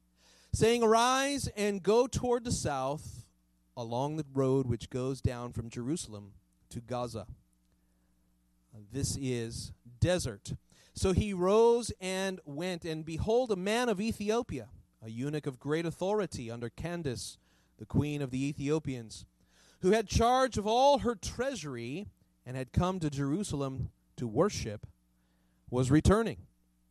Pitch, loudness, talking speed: 130 Hz, -32 LUFS, 130 wpm